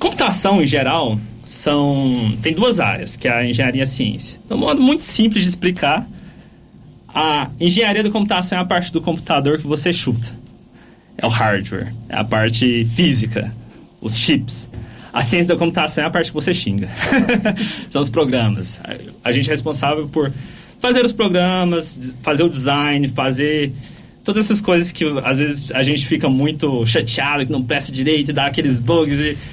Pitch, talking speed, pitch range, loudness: 145 Hz, 175 wpm, 125-175 Hz, -17 LUFS